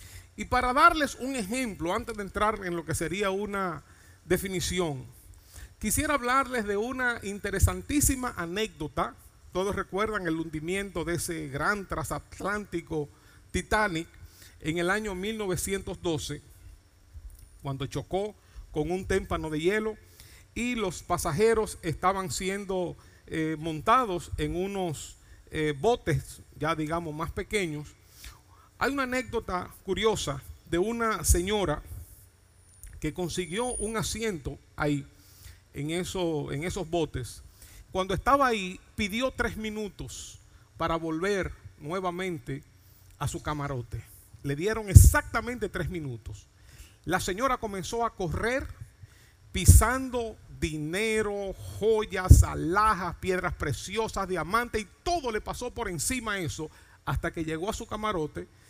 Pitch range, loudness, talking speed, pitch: 135-210 Hz, -29 LUFS, 120 wpm, 175 Hz